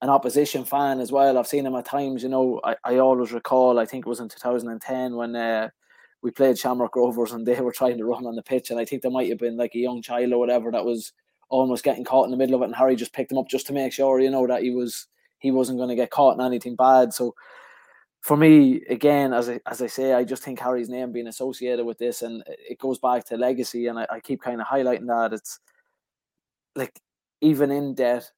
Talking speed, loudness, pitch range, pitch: 255 wpm, -23 LUFS, 120-130 Hz, 125 Hz